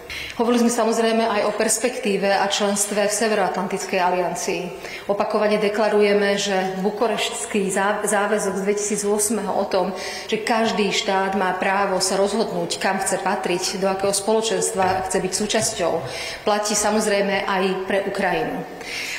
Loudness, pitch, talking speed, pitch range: -21 LUFS, 200 Hz, 130 wpm, 190-215 Hz